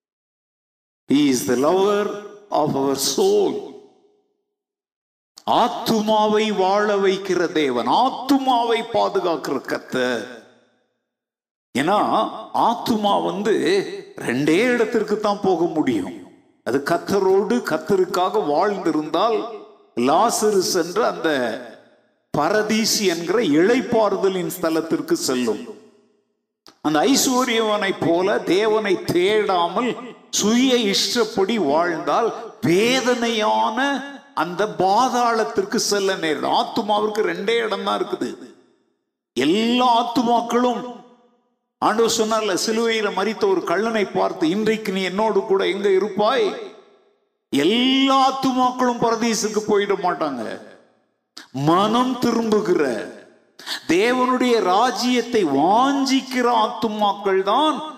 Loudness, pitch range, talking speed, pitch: -19 LUFS, 205-270 Hz, 70 wpm, 230 Hz